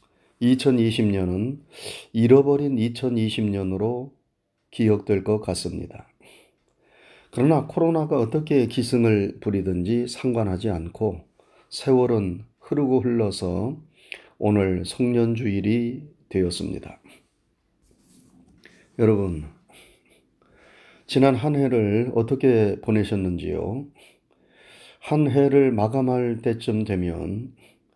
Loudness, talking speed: -23 LUFS, 190 characters per minute